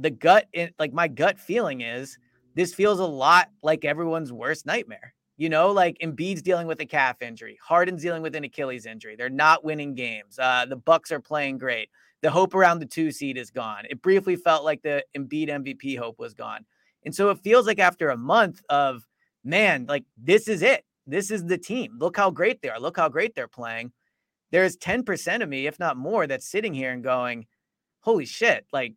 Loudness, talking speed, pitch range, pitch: -24 LUFS, 210 wpm, 130-180 Hz, 155 Hz